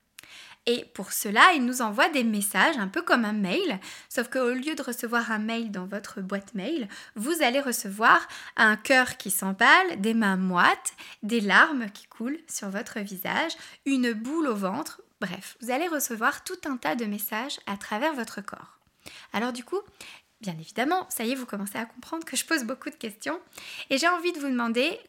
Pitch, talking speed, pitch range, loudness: 240 Hz, 195 wpm, 210-285 Hz, -26 LUFS